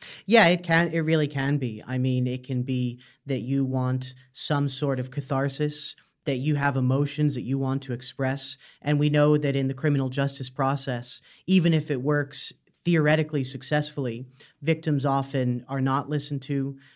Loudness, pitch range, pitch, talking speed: -26 LUFS, 130-150 Hz, 140 Hz, 175 wpm